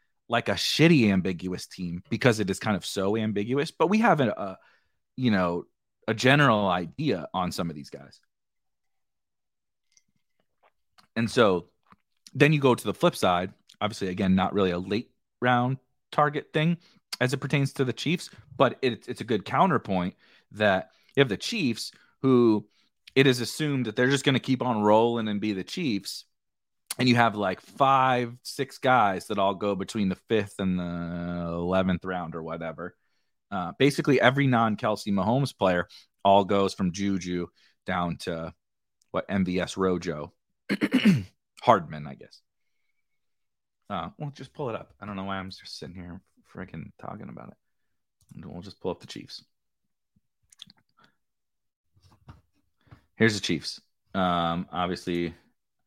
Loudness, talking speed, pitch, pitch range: -26 LUFS, 155 wpm, 105 Hz, 90-130 Hz